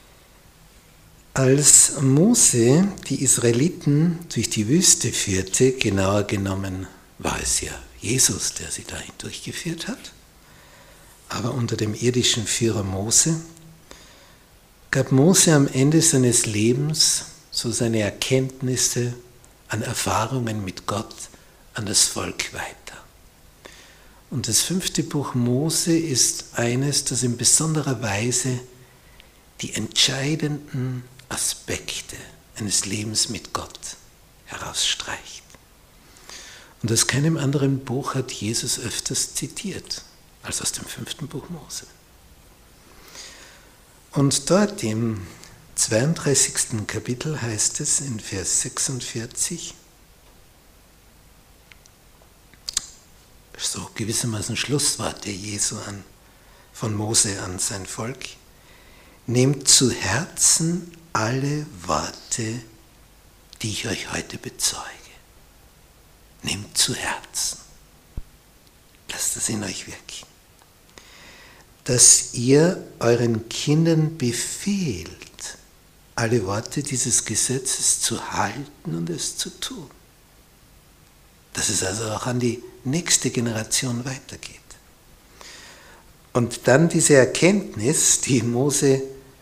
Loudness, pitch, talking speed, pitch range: -21 LUFS, 125 Hz, 95 wpm, 110-140 Hz